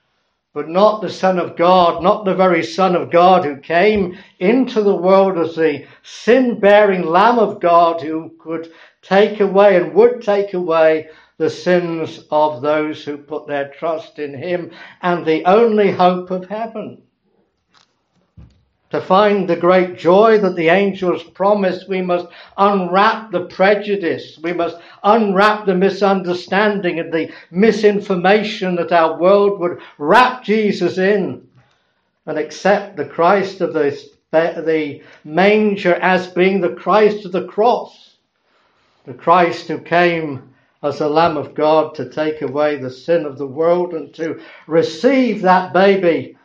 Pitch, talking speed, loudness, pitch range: 175 Hz, 145 wpm, -15 LUFS, 160-200 Hz